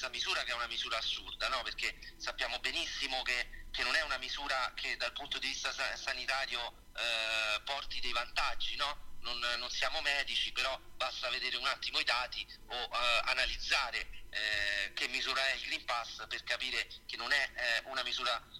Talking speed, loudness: 180 wpm, -34 LUFS